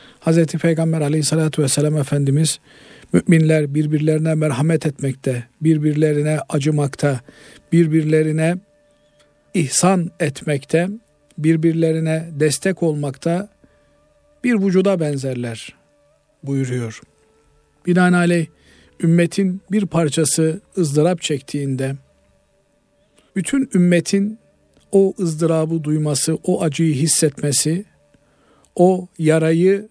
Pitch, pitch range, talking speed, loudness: 160 Hz, 145-170 Hz, 75 wpm, -18 LUFS